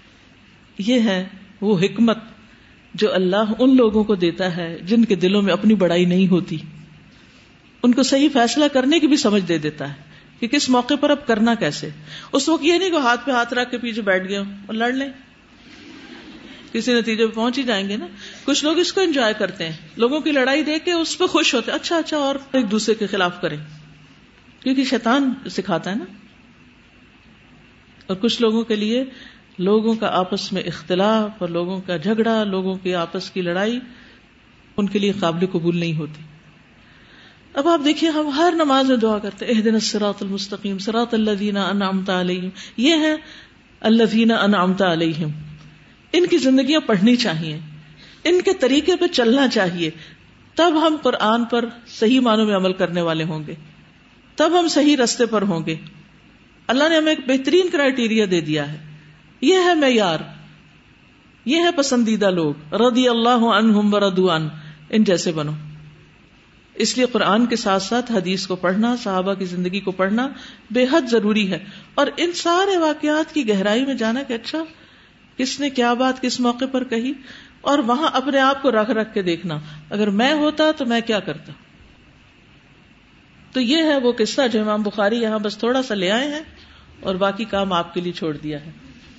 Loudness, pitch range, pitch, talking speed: -19 LUFS, 185-265 Hz, 220 Hz, 180 wpm